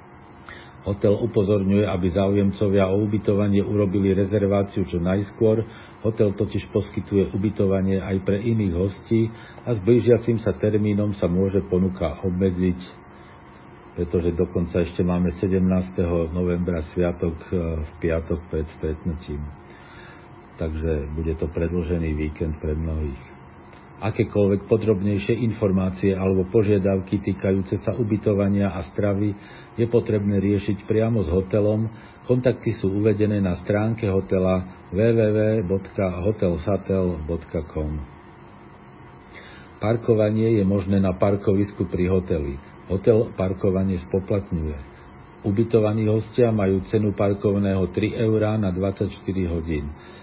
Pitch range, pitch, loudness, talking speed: 90-105 Hz, 95 Hz, -23 LUFS, 105 wpm